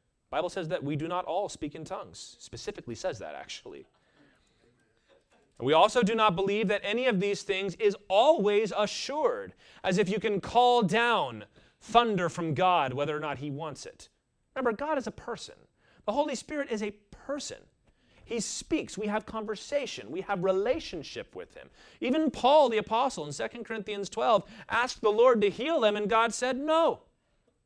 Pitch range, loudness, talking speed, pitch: 195-245 Hz, -28 LUFS, 175 wpm, 215 Hz